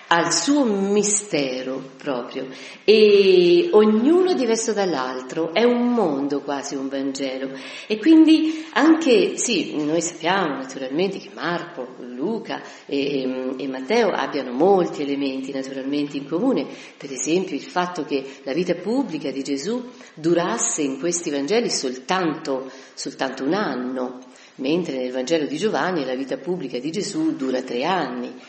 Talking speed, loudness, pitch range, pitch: 135 wpm, -21 LUFS, 135-215 Hz, 155 Hz